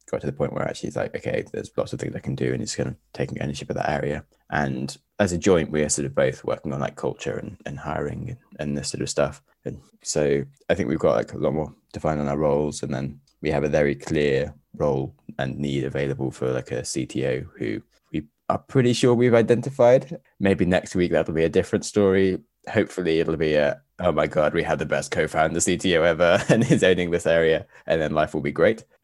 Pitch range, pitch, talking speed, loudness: 70-95 Hz, 80 Hz, 245 wpm, -23 LUFS